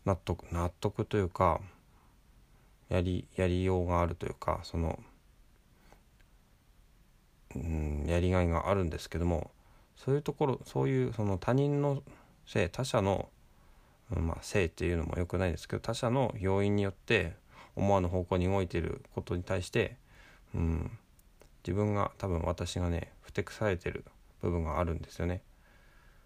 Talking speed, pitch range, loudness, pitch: 300 characters per minute, 85-105 Hz, -33 LUFS, 90 Hz